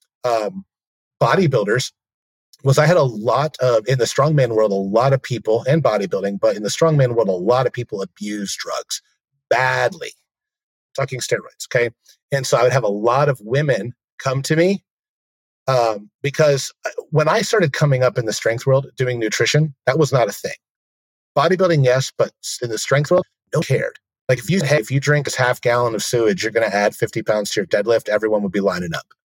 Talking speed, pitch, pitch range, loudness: 205 wpm, 130 Hz, 110-150 Hz, -18 LUFS